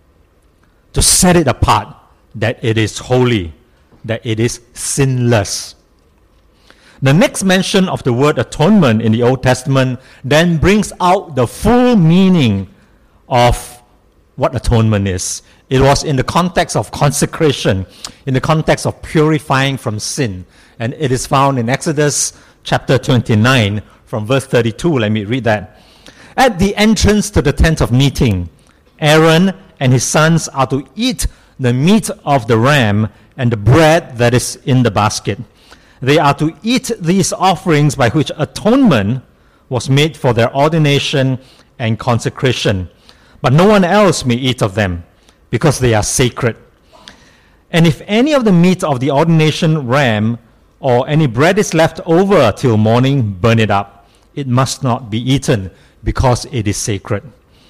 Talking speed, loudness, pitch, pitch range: 155 wpm, -13 LUFS, 130 Hz, 110-155 Hz